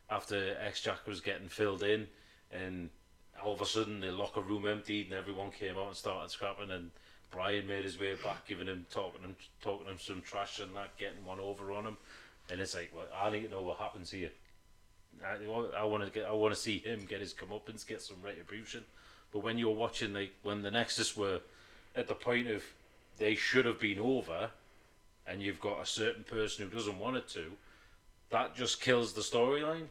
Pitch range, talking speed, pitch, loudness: 95-110 Hz, 210 wpm, 100 Hz, -38 LUFS